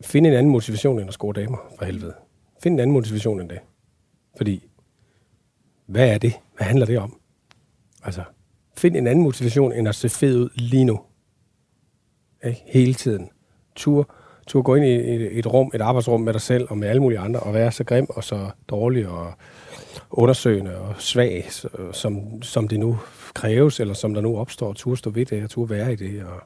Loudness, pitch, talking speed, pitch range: -21 LUFS, 120 Hz, 200 wpm, 105-125 Hz